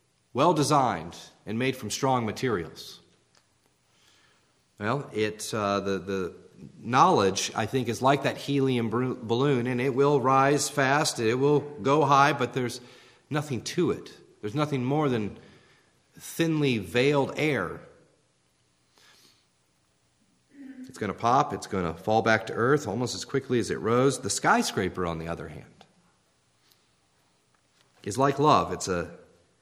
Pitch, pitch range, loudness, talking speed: 120 Hz, 95-140 Hz, -26 LUFS, 140 wpm